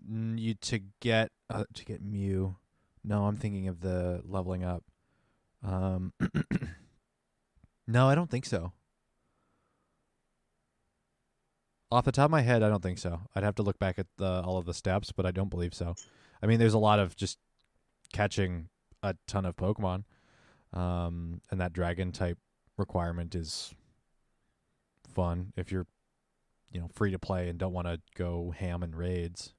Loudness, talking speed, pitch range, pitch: -32 LUFS, 165 wpm, 90-105 Hz, 95 Hz